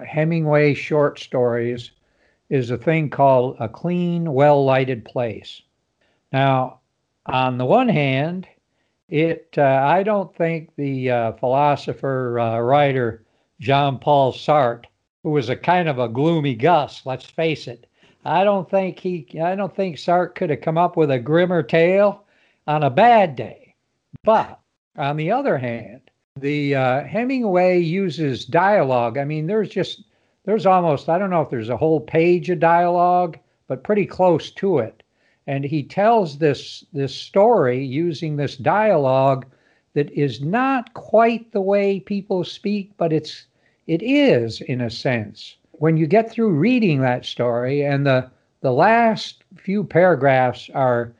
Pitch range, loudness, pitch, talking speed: 130-180 Hz, -19 LUFS, 150 Hz, 150 wpm